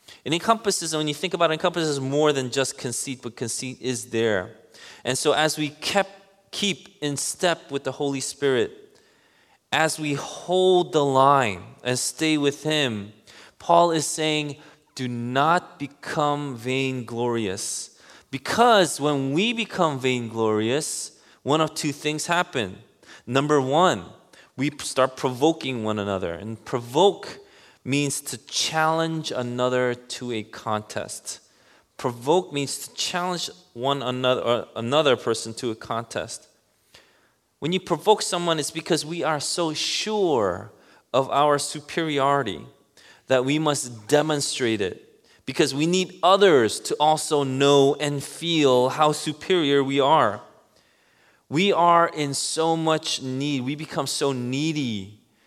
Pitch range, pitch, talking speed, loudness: 130-165 Hz, 145 Hz, 135 wpm, -23 LUFS